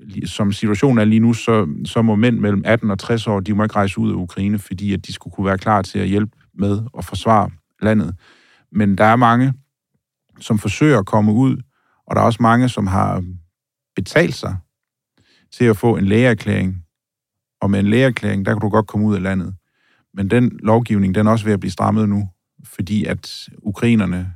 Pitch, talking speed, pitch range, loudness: 105 Hz, 205 wpm, 100-115 Hz, -17 LUFS